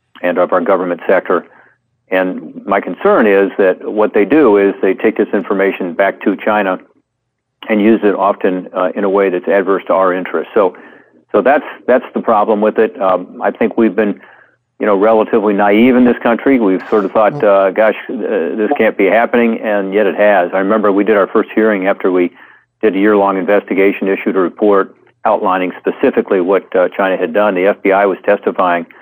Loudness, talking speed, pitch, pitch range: -13 LUFS, 200 wpm, 100 Hz, 95-110 Hz